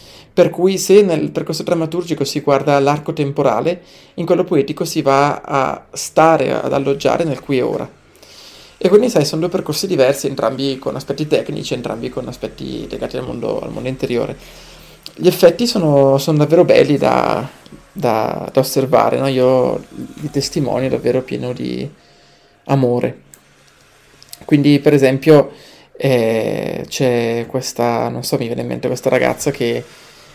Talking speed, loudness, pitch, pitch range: 150 wpm, -16 LUFS, 140 Hz, 130-165 Hz